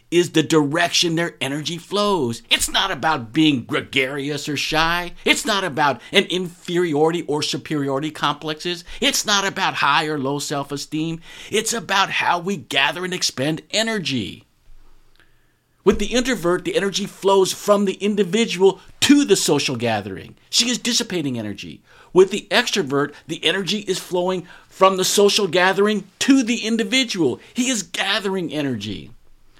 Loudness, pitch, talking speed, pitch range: -19 LUFS, 175 Hz, 145 wpm, 145-200 Hz